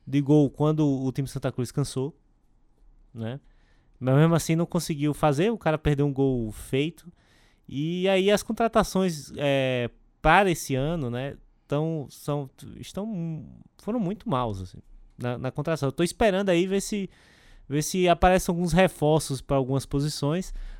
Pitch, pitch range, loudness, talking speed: 150 Hz, 135-175 Hz, -25 LUFS, 155 wpm